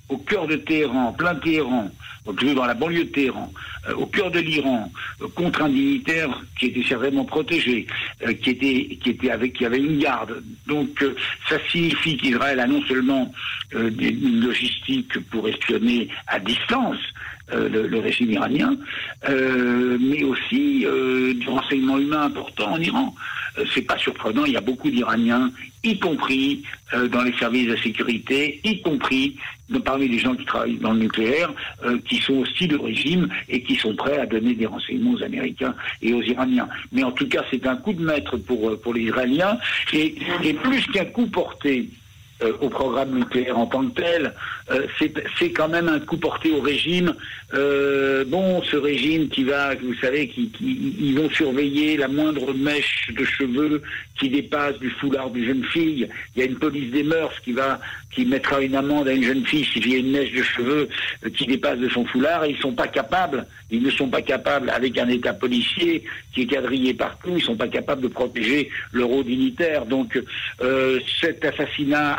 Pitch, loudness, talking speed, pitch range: 140 Hz, -22 LUFS, 190 wpm, 125-160 Hz